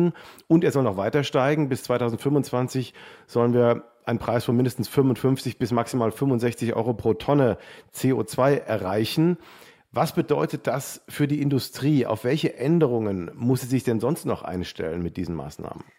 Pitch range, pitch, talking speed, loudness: 115-145 Hz, 125 Hz, 160 wpm, -24 LUFS